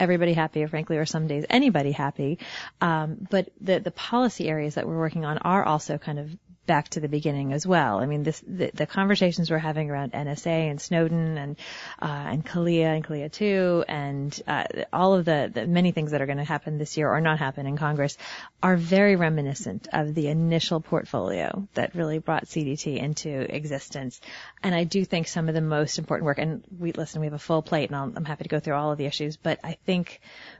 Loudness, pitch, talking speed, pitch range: -26 LUFS, 155 Hz, 220 wpm, 150-170 Hz